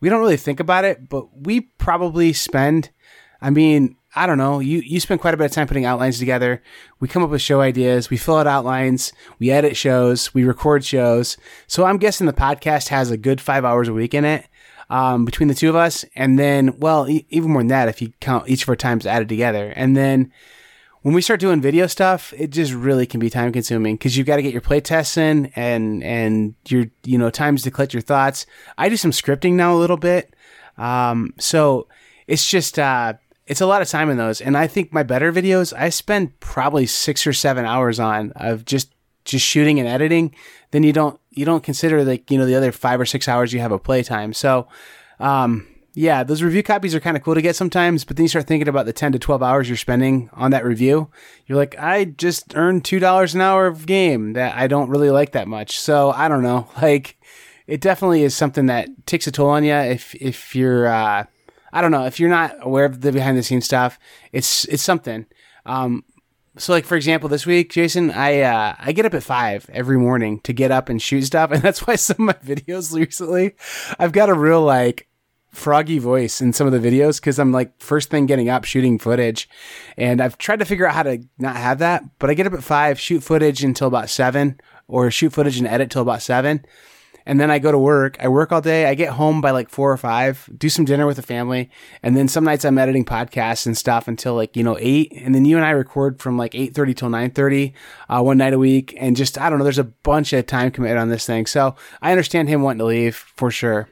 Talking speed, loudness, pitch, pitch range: 240 wpm, -18 LUFS, 140 Hz, 125-155 Hz